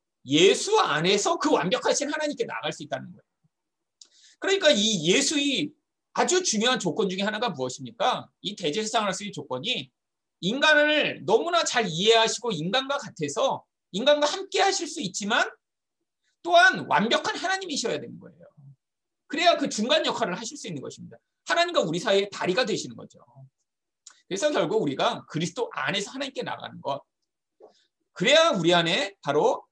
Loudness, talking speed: -24 LUFS, 350 characters per minute